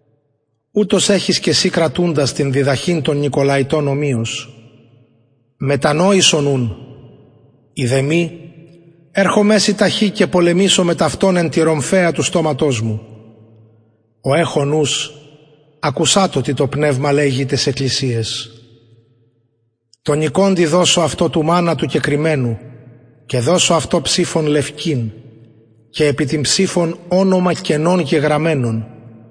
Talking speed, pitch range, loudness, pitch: 115 wpm, 120-170 Hz, -15 LUFS, 150 Hz